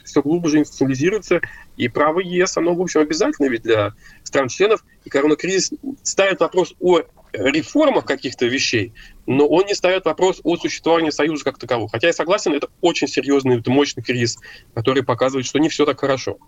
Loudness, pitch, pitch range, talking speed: -18 LUFS, 155 Hz, 135-185 Hz, 165 wpm